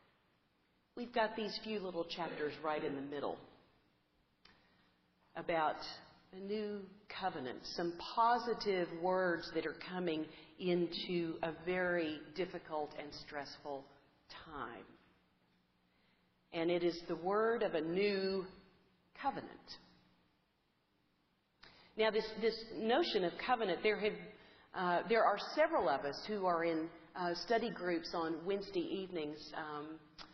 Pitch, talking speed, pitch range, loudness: 175 Hz, 120 wpm, 150-205 Hz, -38 LUFS